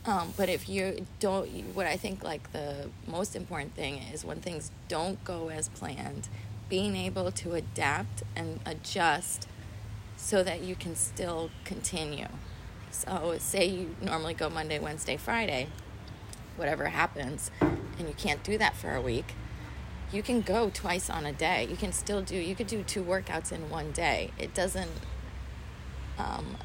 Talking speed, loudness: 160 wpm, -33 LUFS